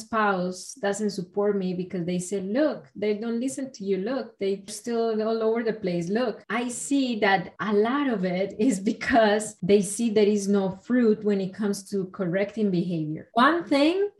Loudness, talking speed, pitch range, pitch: -25 LUFS, 185 wpm, 195-235 Hz, 210 Hz